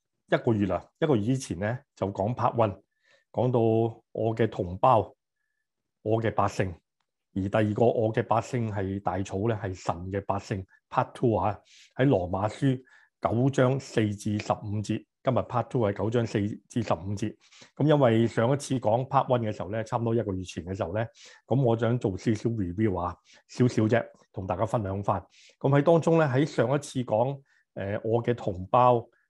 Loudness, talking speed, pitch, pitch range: -27 LUFS, 310 characters per minute, 115 Hz, 100-125 Hz